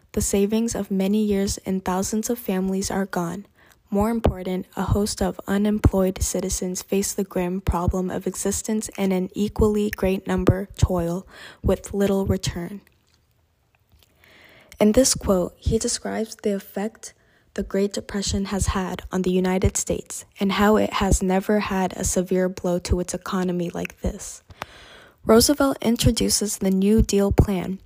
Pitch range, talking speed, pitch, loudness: 185-210 Hz, 150 wpm, 195 Hz, -23 LUFS